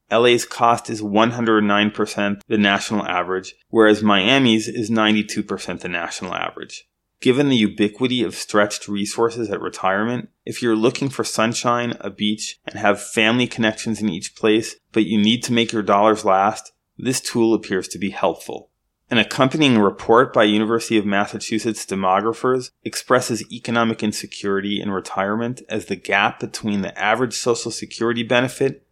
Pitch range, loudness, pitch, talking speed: 105-115 Hz, -19 LUFS, 110 Hz, 150 wpm